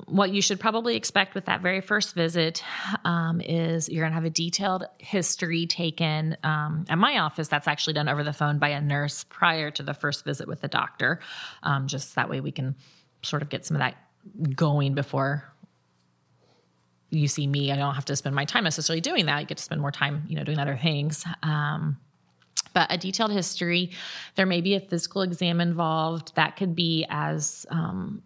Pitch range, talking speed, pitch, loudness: 145-175 Hz, 205 wpm, 160 Hz, -26 LUFS